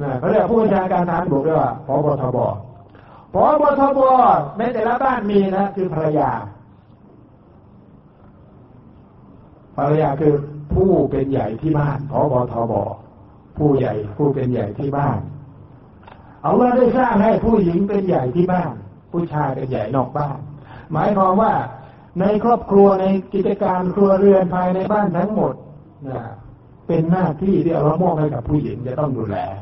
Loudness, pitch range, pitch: -18 LUFS, 125-190 Hz, 150 Hz